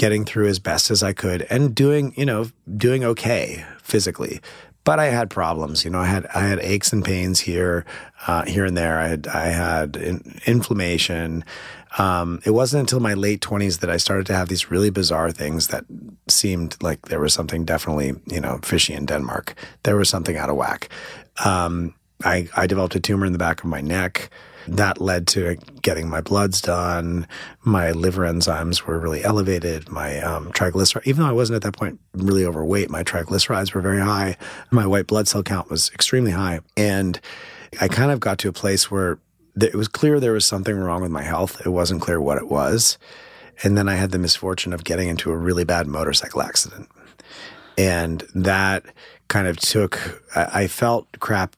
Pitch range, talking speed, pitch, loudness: 85-100 Hz, 195 wpm, 95 Hz, -21 LUFS